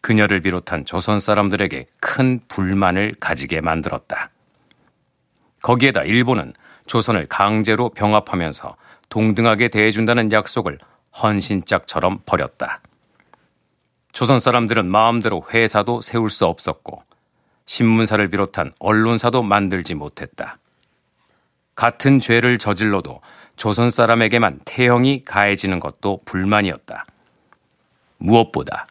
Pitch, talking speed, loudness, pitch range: 105 Hz, 270 characters per minute, -18 LUFS, 95-115 Hz